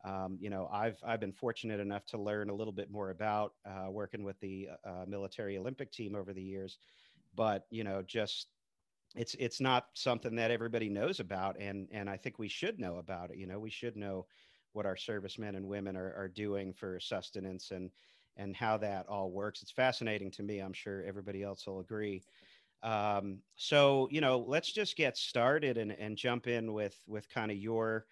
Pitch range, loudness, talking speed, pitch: 95-115 Hz, -38 LUFS, 205 wpm, 100 Hz